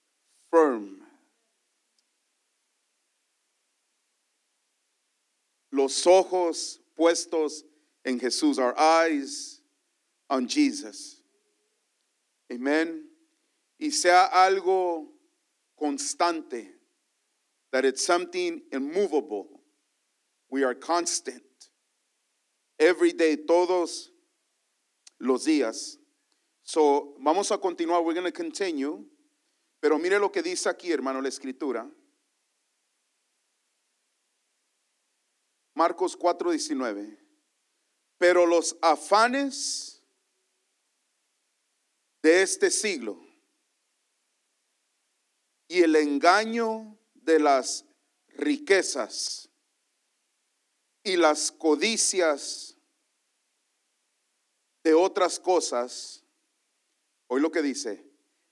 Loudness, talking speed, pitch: -25 LUFS, 70 wpm, 200 Hz